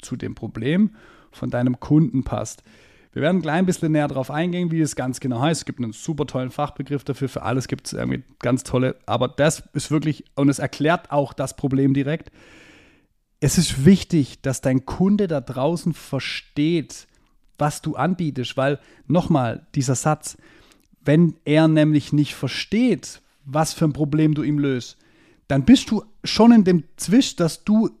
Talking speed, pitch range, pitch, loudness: 175 wpm, 135-160 Hz, 145 Hz, -21 LUFS